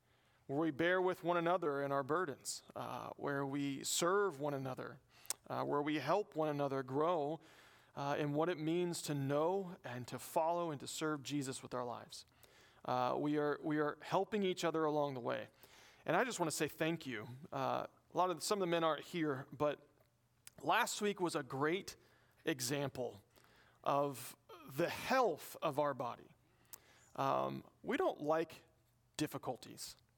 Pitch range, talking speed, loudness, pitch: 135-165 Hz, 170 wpm, -39 LUFS, 150 Hz